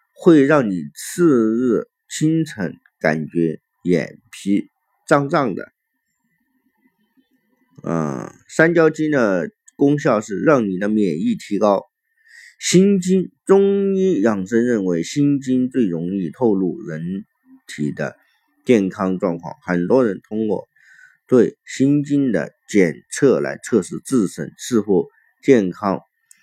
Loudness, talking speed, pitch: -19 LUFS, 160 characters per minute, 160 Hz